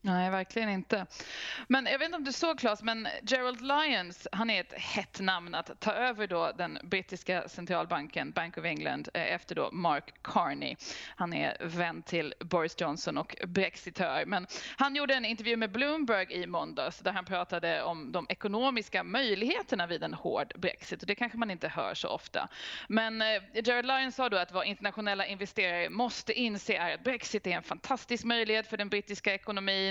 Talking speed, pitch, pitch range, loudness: 185 wpm, 215 Hz, 185-245 Hz, -32 LUFS